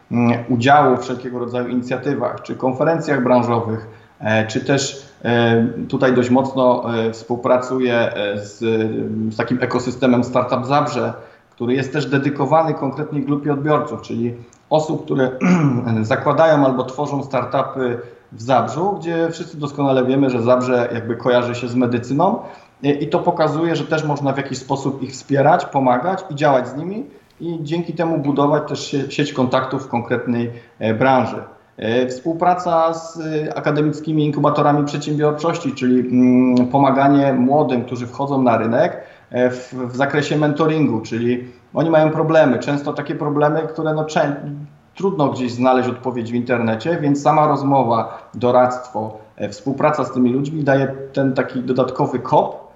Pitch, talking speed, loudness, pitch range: 130 Hz, 130 wpm, -18 LUFS, 125-150 Hz